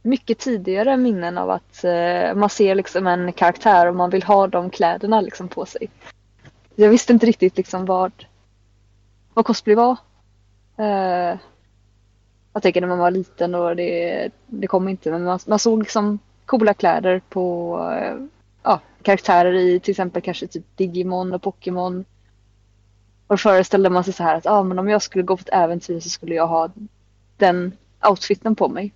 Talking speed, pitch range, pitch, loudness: 175 wpm, 165-205 Hz, 180 Hz, -19 LUFS